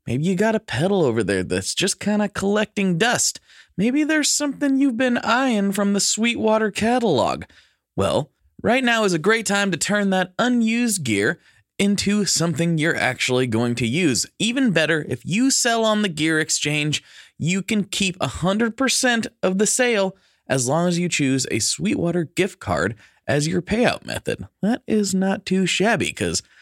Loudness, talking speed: -20 LUFS, 175 wpm